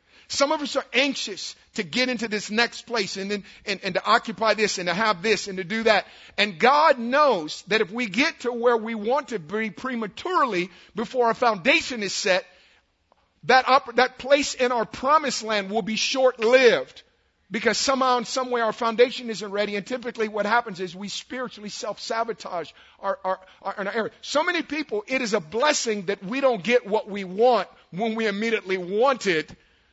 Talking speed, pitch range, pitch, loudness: 195 wpm, 205-255 Hz, 225 Hz, -23 LUFS